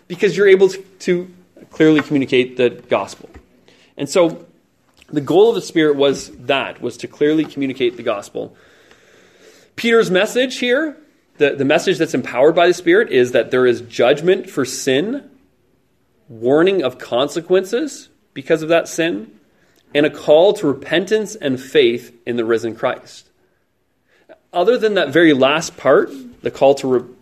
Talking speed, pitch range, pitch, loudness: 150 wpm, 140-220 Hz, 170 Hz, -16 LUFS